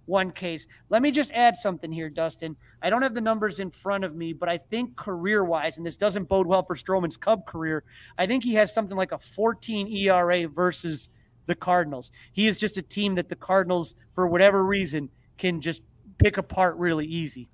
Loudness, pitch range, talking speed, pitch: -25 LUFS, 160-200 Hz, 205 wpm, 180 Hz